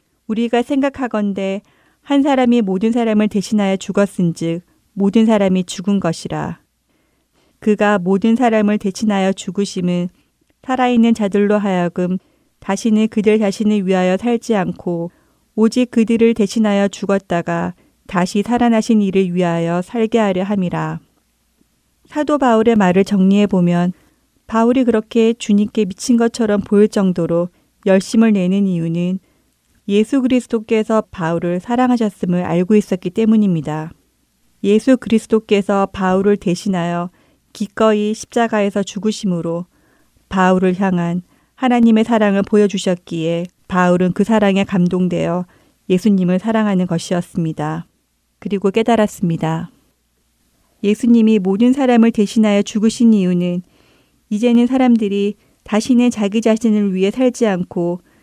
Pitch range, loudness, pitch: 180-225 Hz, -16 LUFS, 205 Hz